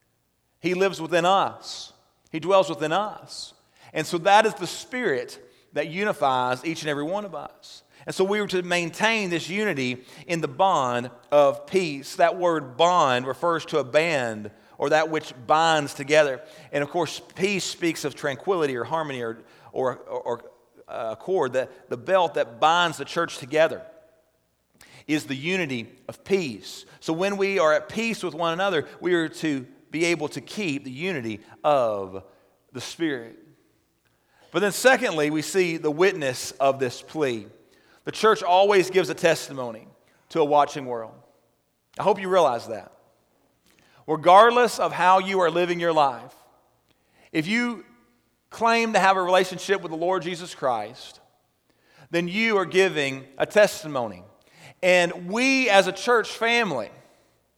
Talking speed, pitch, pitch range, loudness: 160 wpm, 165 Hz, 145-190 Hz, -23 LUFS